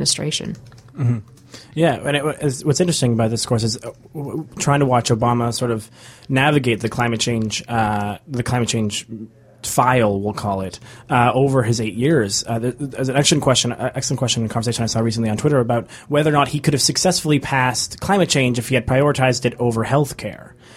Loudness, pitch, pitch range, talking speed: -19 LUFS, 125 Hz, 115-140 Hz, 210 wpm